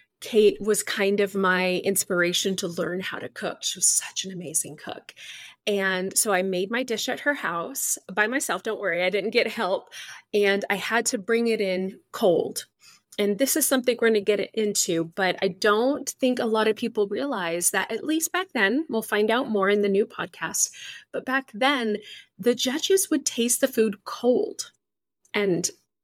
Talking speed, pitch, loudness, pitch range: 195 wpm, 210 Hz, -24 LUFS, 190-250 Hz